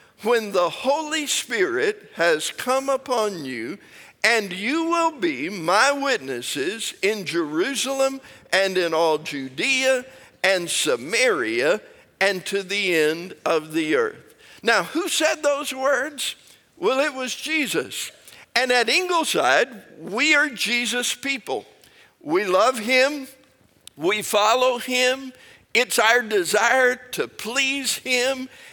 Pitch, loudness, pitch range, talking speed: 260 Hz, -21 LUFS, 215-300 Hz, 120 wpm